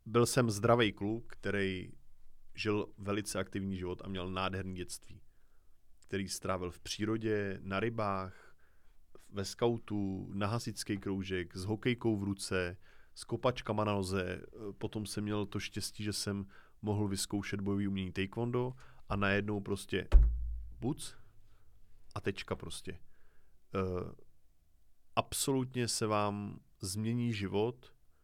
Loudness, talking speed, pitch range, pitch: -36 LUFS, 120 wpm, 95-110 Hz, 100 Hz